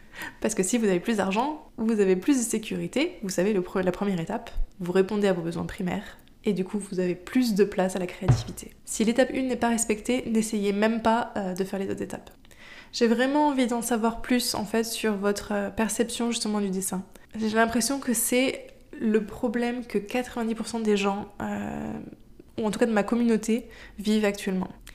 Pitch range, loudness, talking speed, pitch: 195-235 Hz, -26 LUFS, 205 wpm, 215 Hz